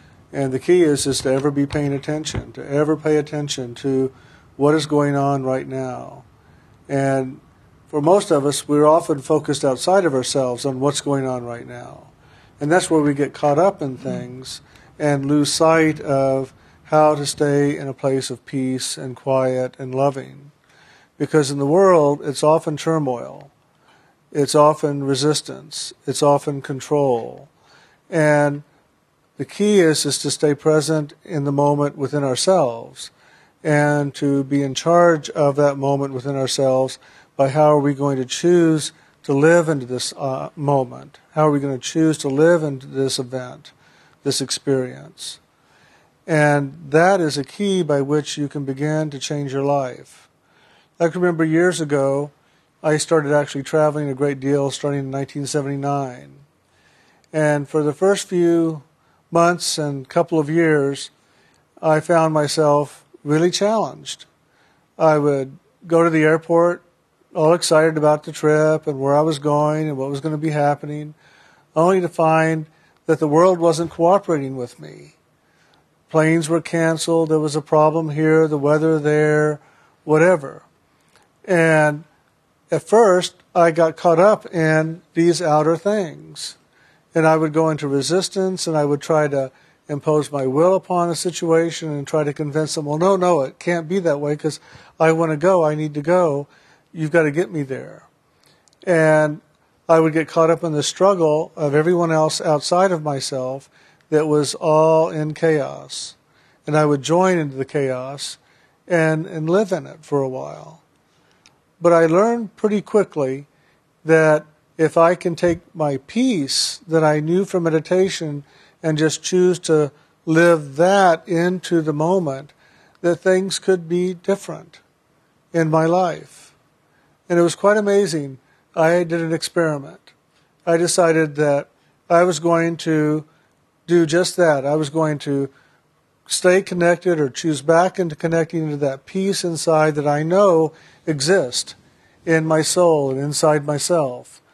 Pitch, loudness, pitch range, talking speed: 155 Hz, -18 LUFS, 145-165 Hz, 160 wpm